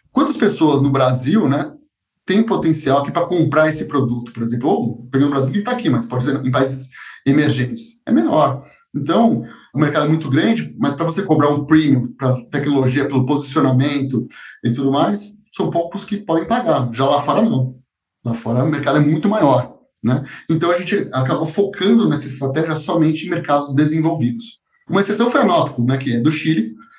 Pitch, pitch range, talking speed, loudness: 145 Hz, 130-170 Hz, 180 wpm, -17 LUFS